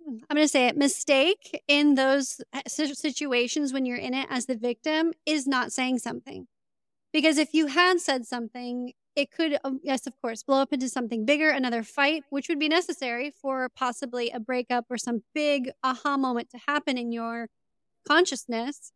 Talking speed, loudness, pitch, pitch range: 175 wpm, -26 LUFS, 270 Hz, 245-295 Hz